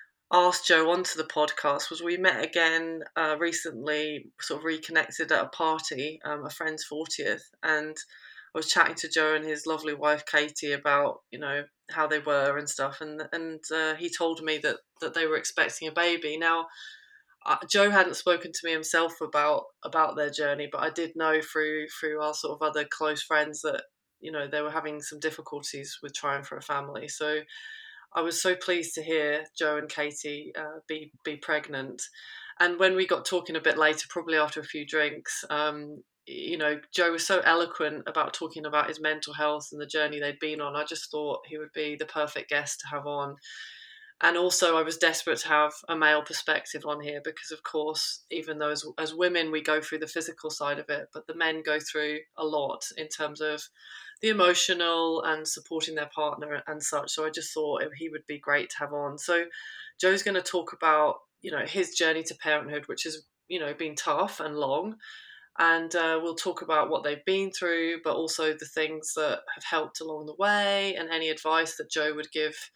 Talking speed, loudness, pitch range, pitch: 205 wpm, -28 LUFS, 150-165 Hz, 155 Hz